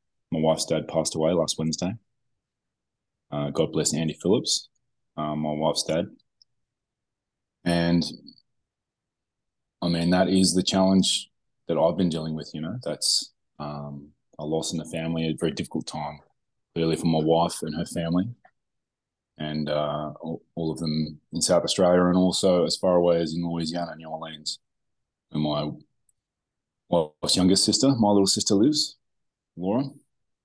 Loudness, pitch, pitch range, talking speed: -25 LUFS, 80 Hz, 75-90 Hz, 150 wpm